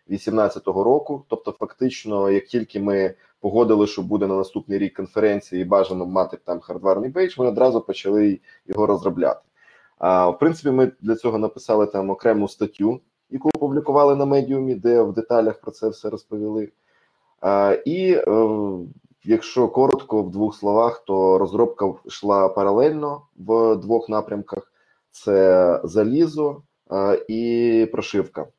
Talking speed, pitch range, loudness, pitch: 130 wpm, 100-120 Hz, -20 LUFS, 110 Hz